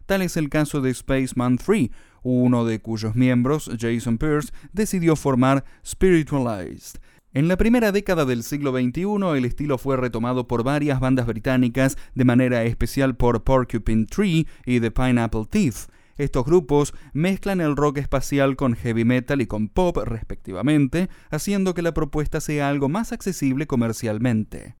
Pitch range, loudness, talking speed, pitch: 120-155 Hz, -22 LUFS, 150 wpm, 135 Hz